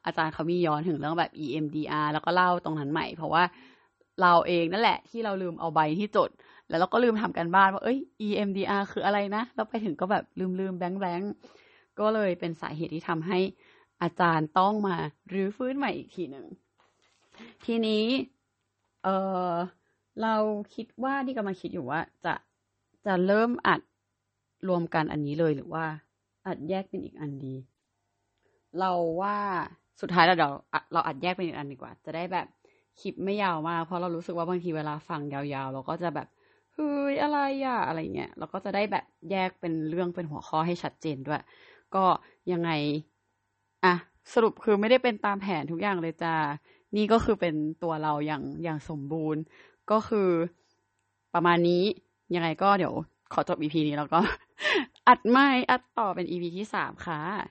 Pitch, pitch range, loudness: 175 Hz, 155-205 Hz, -28 LUFS